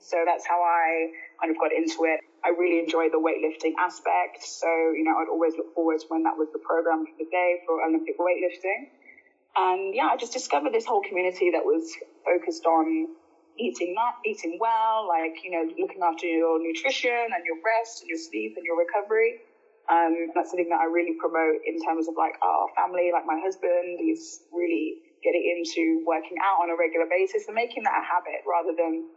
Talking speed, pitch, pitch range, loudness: 205 wpm, 170 Hz, 165-220 Hz, -26 LUFS